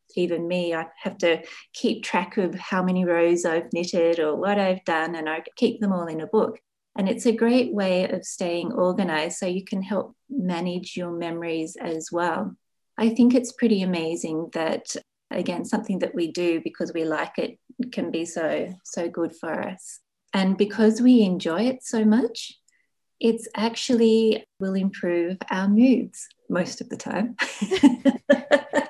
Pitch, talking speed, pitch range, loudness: 190 Hz, 170 wpm, 170-230 Hz, -24 LUFS